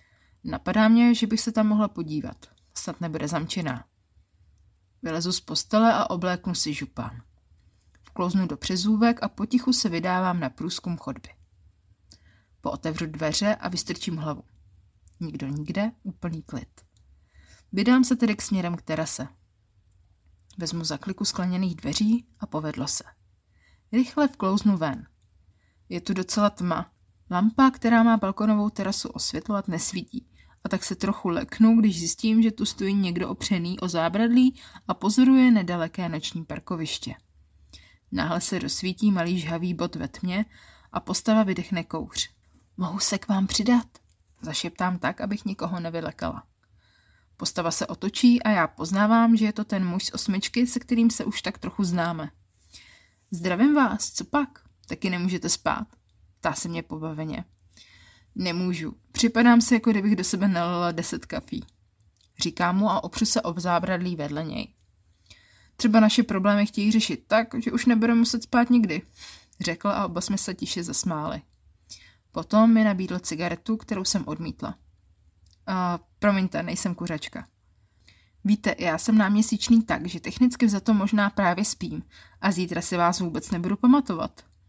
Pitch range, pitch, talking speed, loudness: 130-210 Hz, 180 Hz, 145 wpm, -25 LUFS